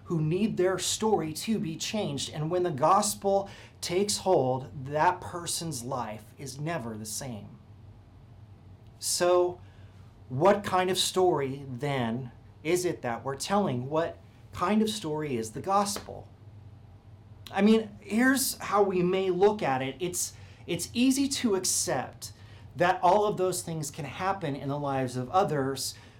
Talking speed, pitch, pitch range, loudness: 145 wpm, 150 Hz, 115-185 Hz, -28 LUFS